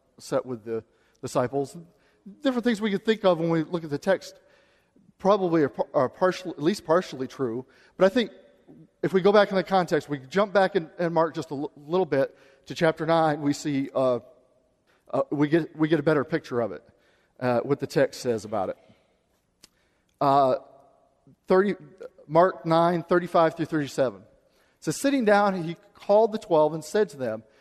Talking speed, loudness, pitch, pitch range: 190 wpm, -25 LUFS, 165 Hz, 145-190 Hz